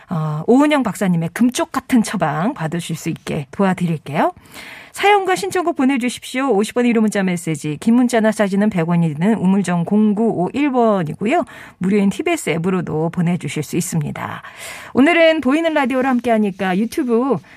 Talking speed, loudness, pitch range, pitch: 345 characters per minute, -17 LUFS, 175-260 Hz, 210 Hz